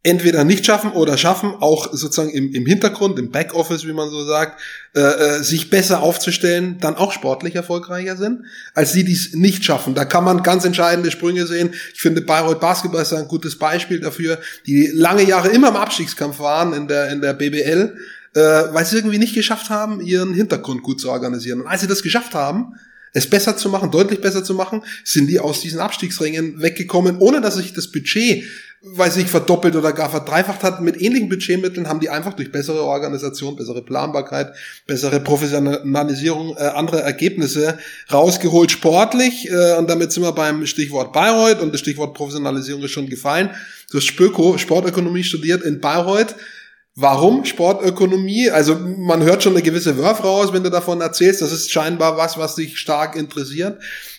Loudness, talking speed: -17 LUFS, 180 wpm